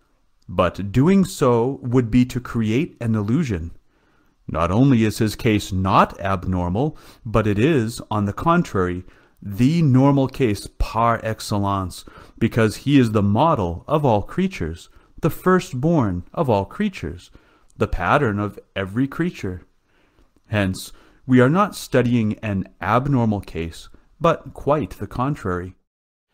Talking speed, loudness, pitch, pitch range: 130 wpm, -20 LUFS, 110 Hz, 95-130 Hz